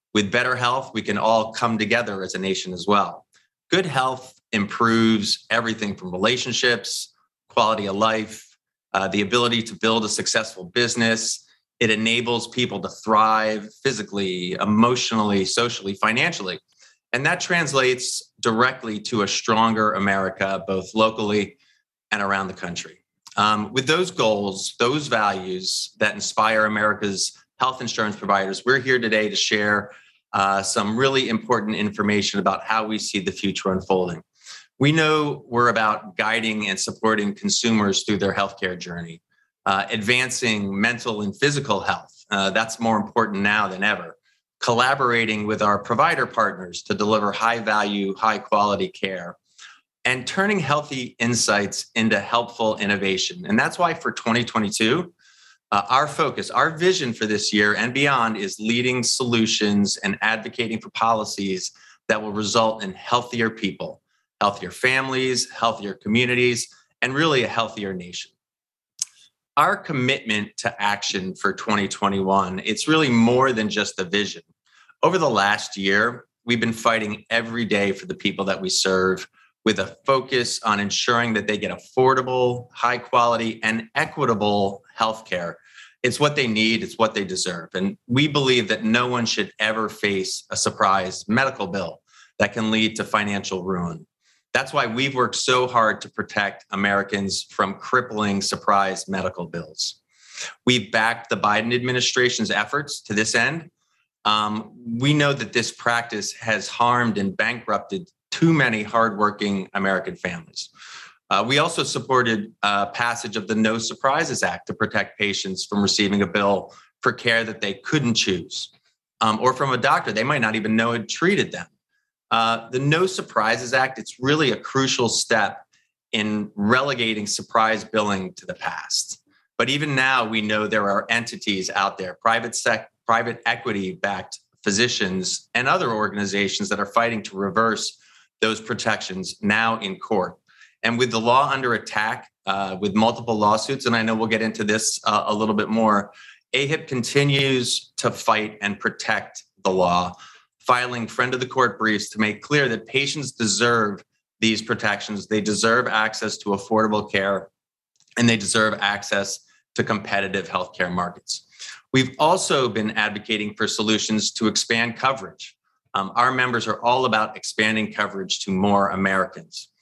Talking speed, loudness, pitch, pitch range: 150 wpm, -21 LUFS, 110 Hz, 100-120 Hz